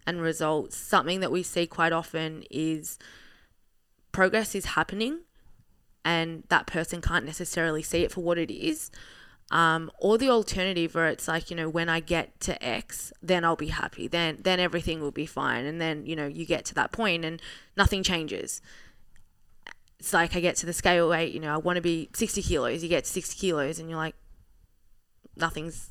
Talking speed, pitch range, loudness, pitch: 195 wpm, 160-180 Hz, -28 LUFS, 165 Hz